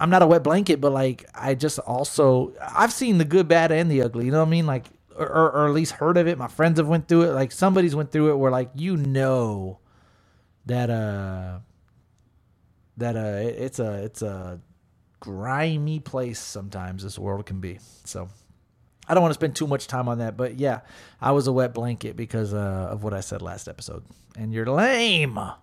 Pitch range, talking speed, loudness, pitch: 105-155 Hz, 210 wpm, -23 LUFS, 125 Hz